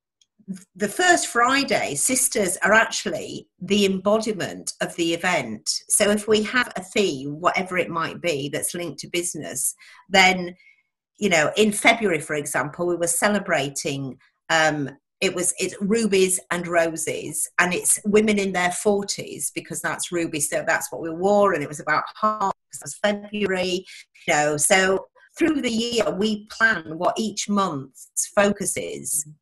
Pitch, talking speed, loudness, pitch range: 190 Hz, 155 wpm, -22 LUFS, 165-210 Hz